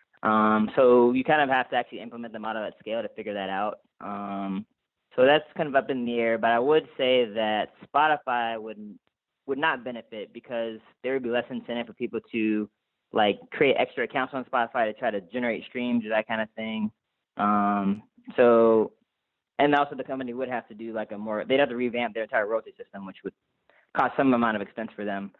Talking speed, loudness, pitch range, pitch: 215 wpm, -26 LUFS, 110-130 Hz, 115 Hz